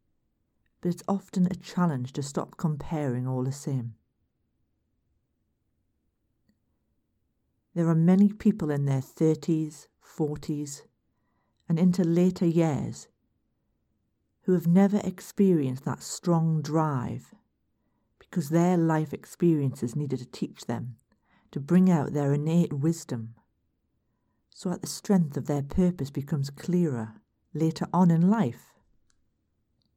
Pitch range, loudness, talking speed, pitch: 130-175 Hz, -27 LUFS, 115 wpm, 155 Hz